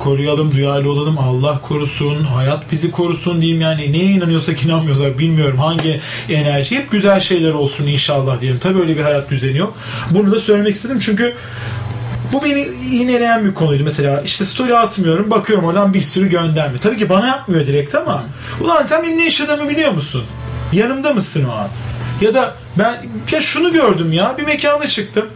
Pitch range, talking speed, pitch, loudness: 145-215 Hz, 170 wpm, 165 Hz, -15 LUFS